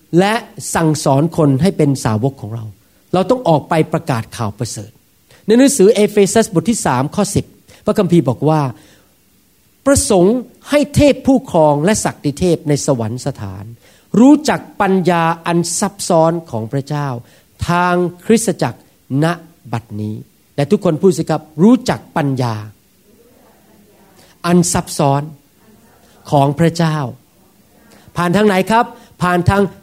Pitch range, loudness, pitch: 130-190 Hz, -15 LUFS, 160 Hz